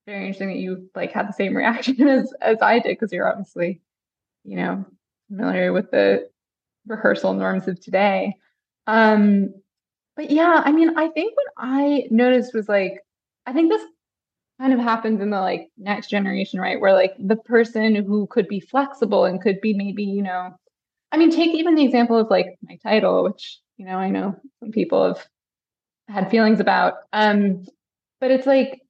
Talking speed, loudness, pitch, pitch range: 185 wpm, -20 LUFS, 215 Hz, 195-260 Hz